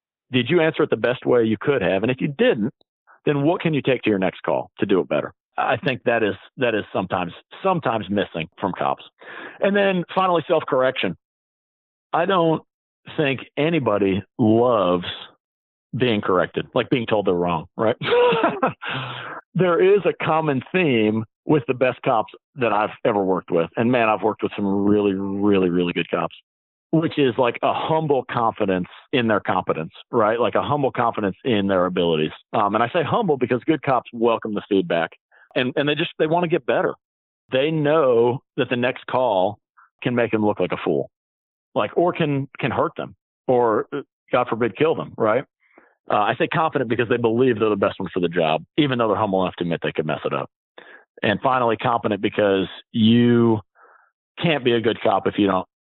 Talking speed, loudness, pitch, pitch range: 195 wpm, -21 LUFS, 120 Hz, 100-150 Hz